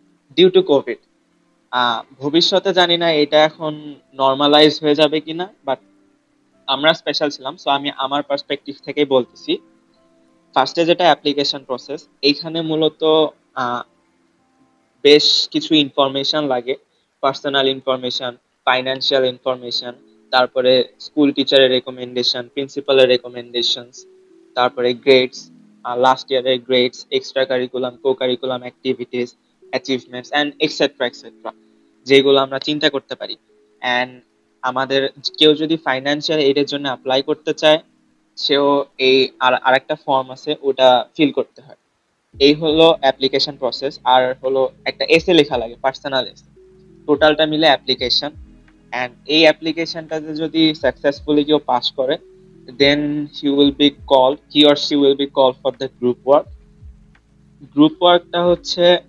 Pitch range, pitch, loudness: 130-155 Hz, 140 Hz, -17 LUFS